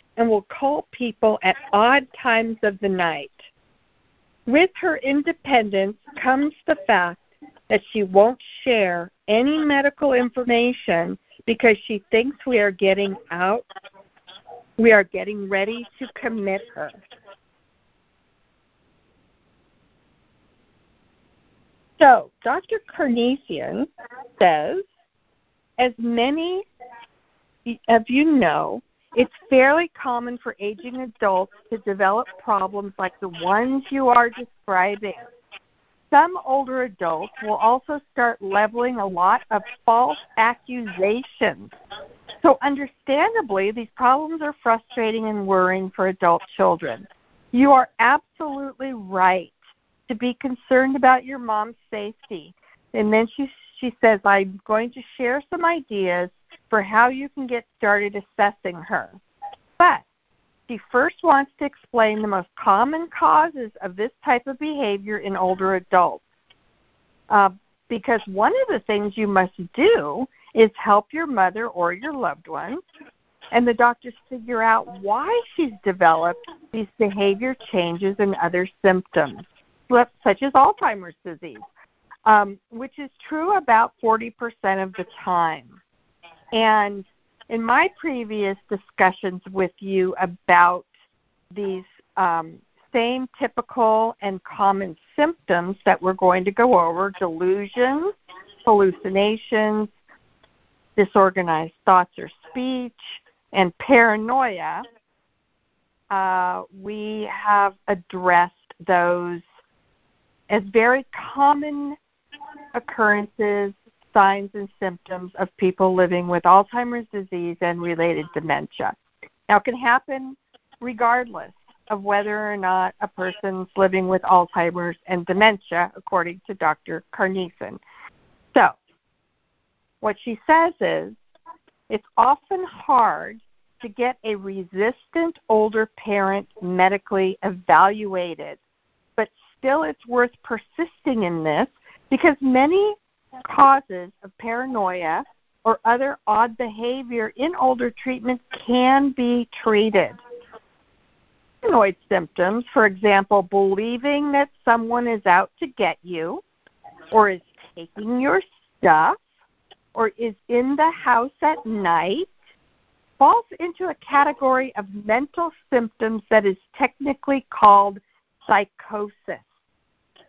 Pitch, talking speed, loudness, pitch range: 220 Hz, 115 wpm, -20 LUFS, 195-260 Hz